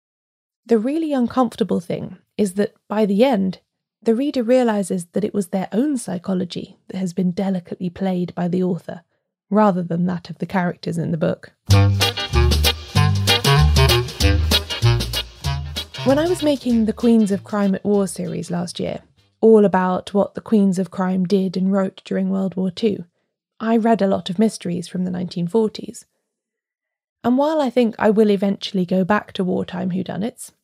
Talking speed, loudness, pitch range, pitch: 165 wpm, -19 LUFS, 175-215 Hz, 190 Hz